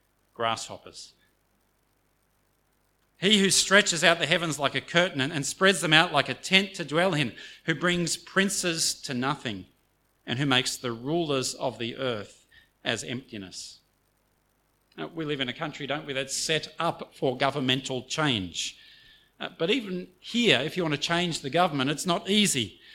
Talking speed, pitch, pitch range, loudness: 160 wpm, 145 Hz, 130-170 Hz, -26 LUFS